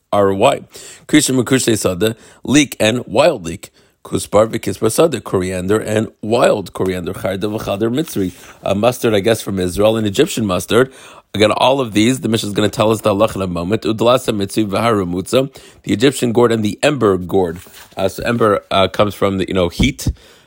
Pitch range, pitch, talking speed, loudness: 95-115 Hz, 105 Hz, 165 wpm, -16 LUFS